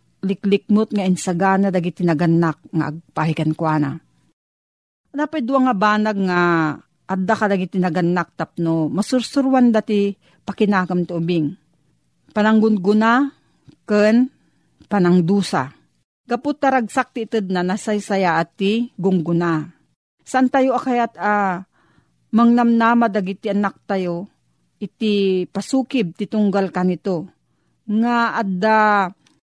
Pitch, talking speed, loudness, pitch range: 195 Hz, 100 wpm, -19 LUFS, 170-220 Hz